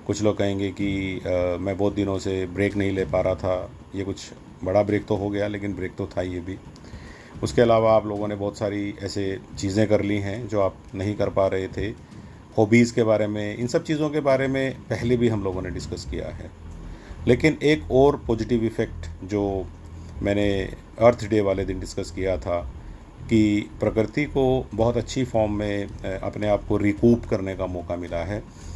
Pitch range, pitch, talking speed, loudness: 95-110 Hz, 100 Hz, 200 wpm, -24 LUFS